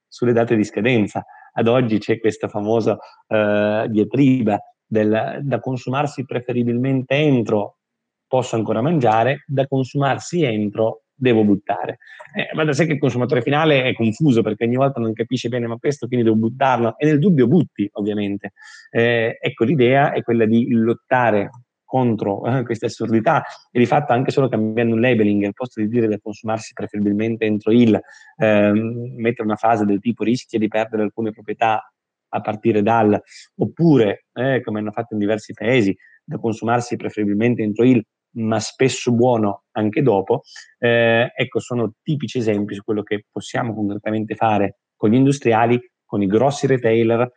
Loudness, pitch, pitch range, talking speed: -19 LUFS, 115 Hz, 110-125 Hz, 160 wpm